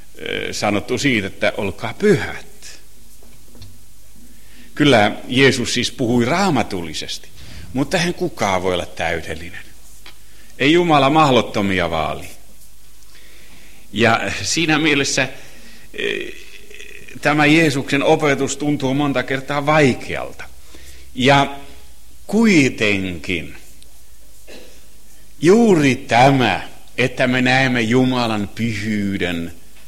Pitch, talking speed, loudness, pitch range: 125 Hz, 80 wpm, -17 LUFS, 95-145 Hz